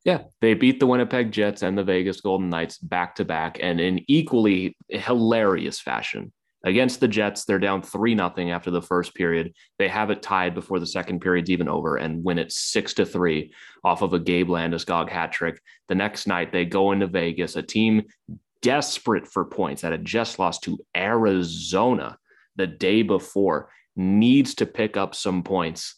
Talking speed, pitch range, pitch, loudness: 185 wpm, 90-110 Hz, 95 Hz, -23 LUFS